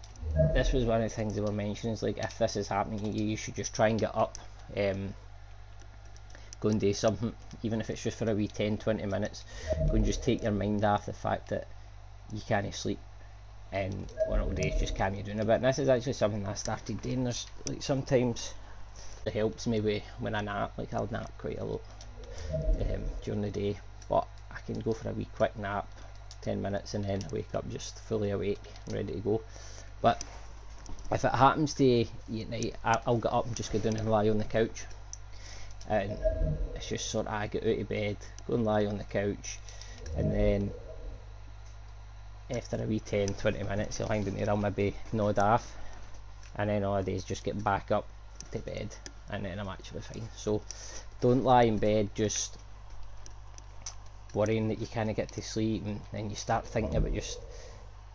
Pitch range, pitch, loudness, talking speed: 100-110 Hz, 105 Hz, -32 LUFS, 210 wpm